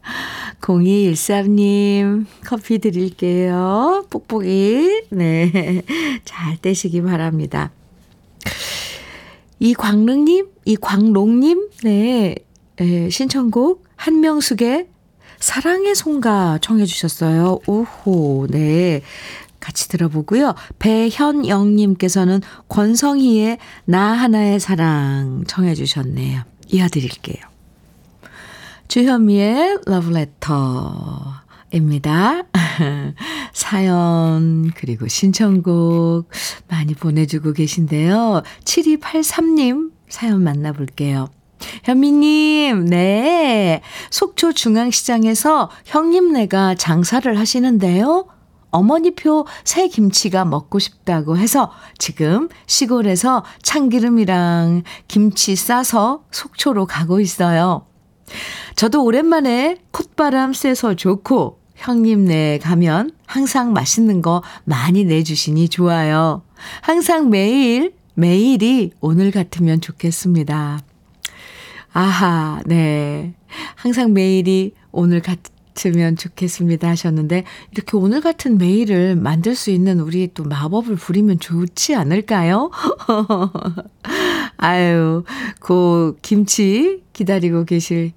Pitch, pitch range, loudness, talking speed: 195 Hz, 170-245 Hz, -16 LUFS, 200 characters per minute